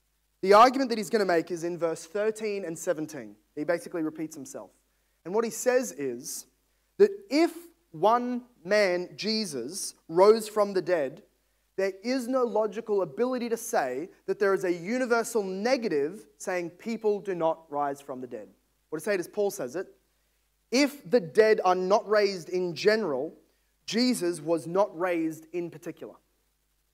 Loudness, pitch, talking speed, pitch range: -27 LUFS, 200 Hz, 165 wpm, 170-230 Hz